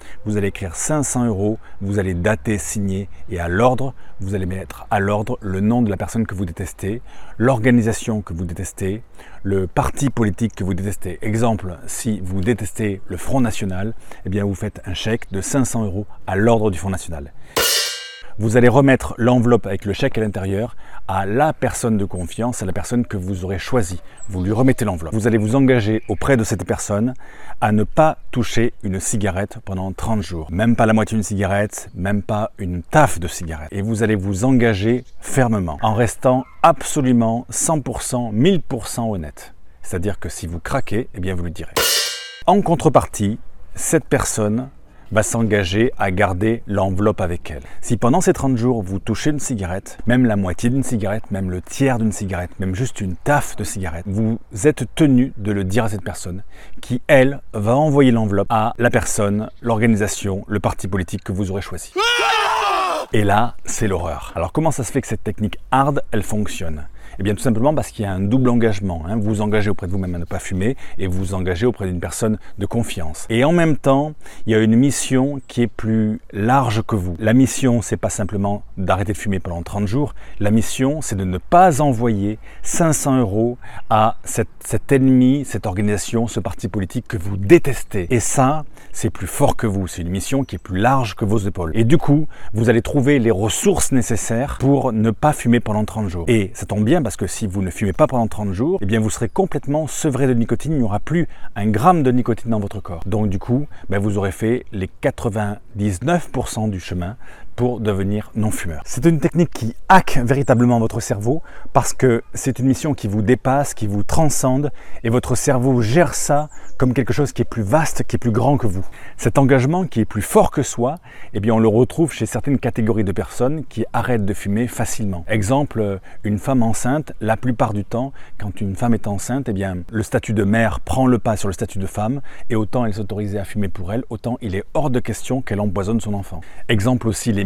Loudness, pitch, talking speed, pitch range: -19 LUFS, 110 Hz, 210 wpm, 100-125 Hz